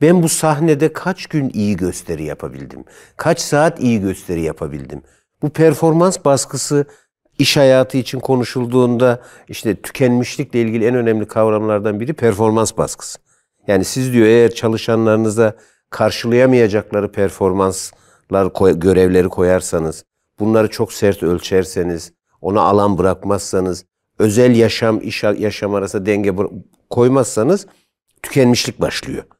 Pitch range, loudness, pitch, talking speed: 100-130 Hz, -15 LUFS, 110 Hz, 110 wpm